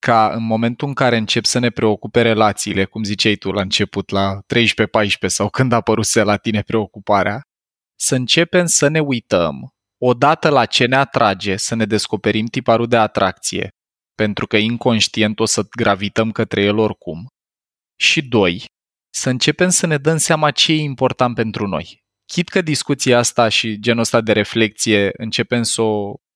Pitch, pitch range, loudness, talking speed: 115 Hz, 105-130 Hz, -16 LUFS, 165 wpm